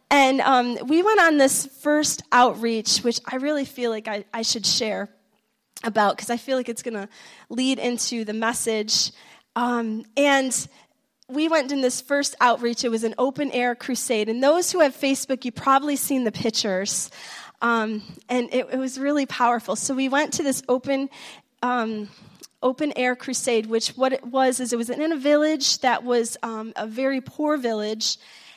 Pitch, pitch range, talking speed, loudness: 250 Hz, 230-270 Hz, 180 wpm, -22 LUFS